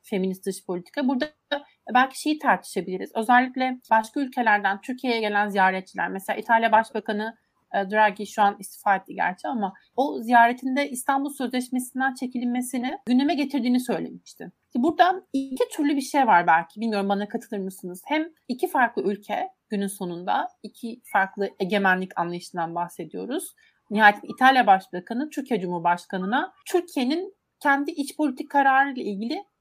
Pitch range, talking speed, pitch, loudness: 200-280 Hz, 130 wpm, 245 Hz, -24 LUFS